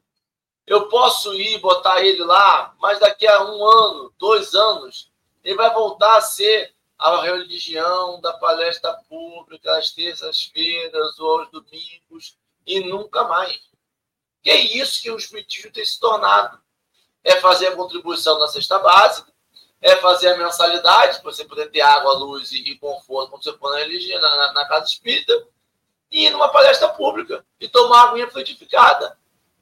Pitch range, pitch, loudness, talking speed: 170-265 Hz, 190 Hz, -16 LUFS, 160 wpm